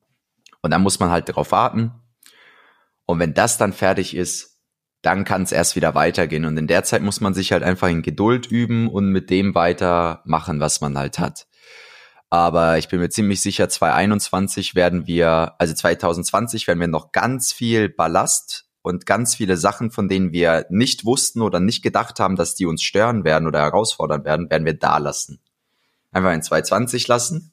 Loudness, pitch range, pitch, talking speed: -19 LUFS, 85-105 Hz, 95 Hz, 185 wpm